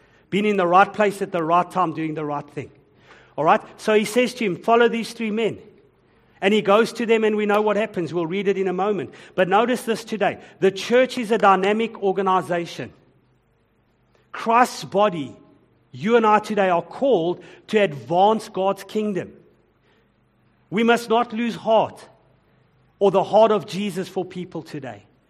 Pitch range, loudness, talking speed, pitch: 170-215 Hz, -21 LUFS, 180 wpm, 195 Hz